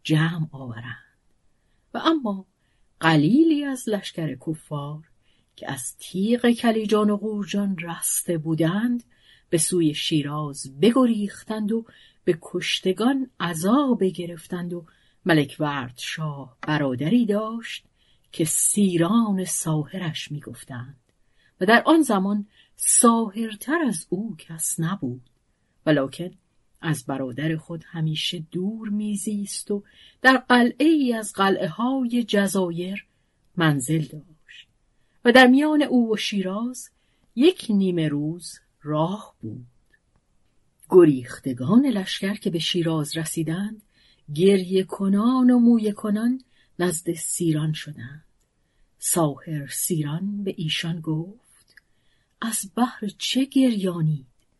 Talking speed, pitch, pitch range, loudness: 105 wpm, 180 Hz, 155-220 Hz, -23 LUFS